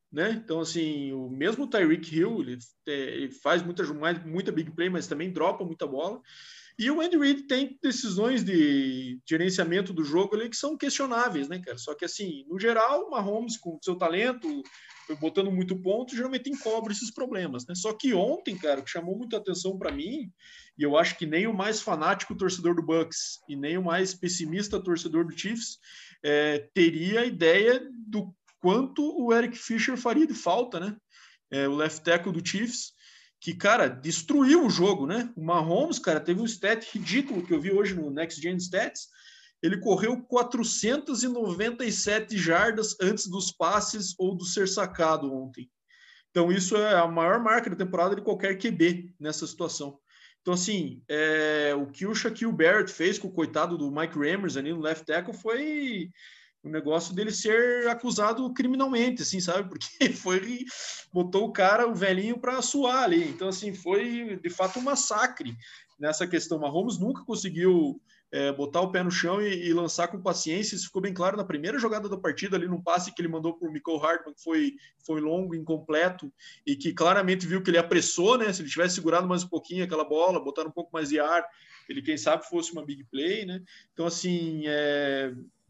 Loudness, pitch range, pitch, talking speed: -27 LUFS, 165-230 Hz, 185 Hz, 185 wpm